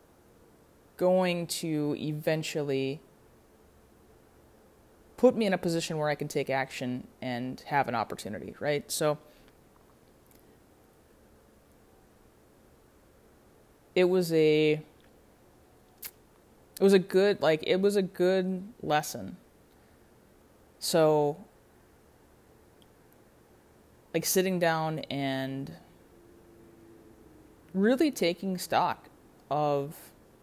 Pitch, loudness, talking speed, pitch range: 150 Hz, -29 LUFS, 80 wpm, 125-180 Hz